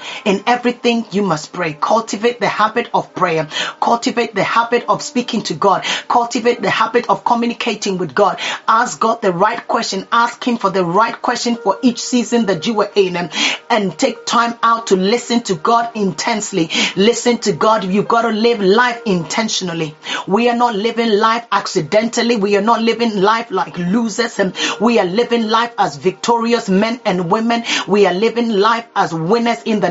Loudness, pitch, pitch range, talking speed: -15 LUFS, 225 Hz, 195-235 Hz, 185 wpm